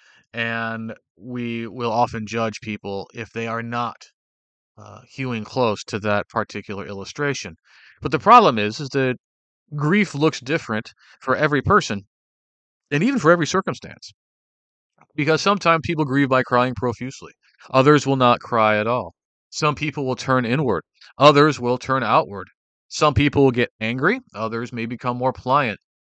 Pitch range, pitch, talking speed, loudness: 110-145 Hz, 125 Hz, 150 wpm, -20 LUFS